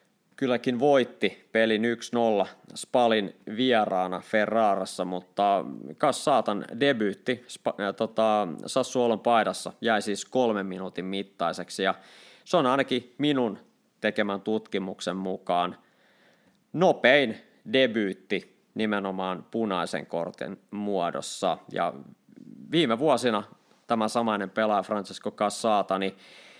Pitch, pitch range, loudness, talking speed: 105 Hz, 95-120 Hz, -27 LUFS, 95 wpm